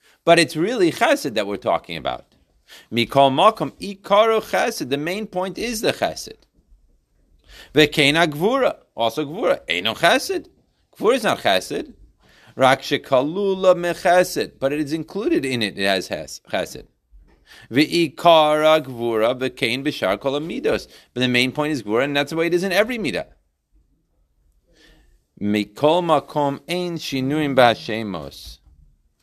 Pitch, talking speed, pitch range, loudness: 150 Hz, 140 wpm, 115-175 Hz, -20 LUFS